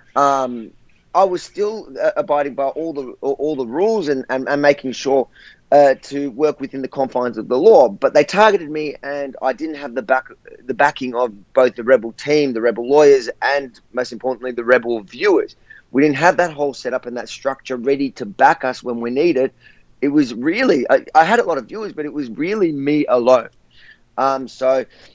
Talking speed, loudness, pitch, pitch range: 210 wpm, -17 LUFS, 140 Hz, 130-150 Hz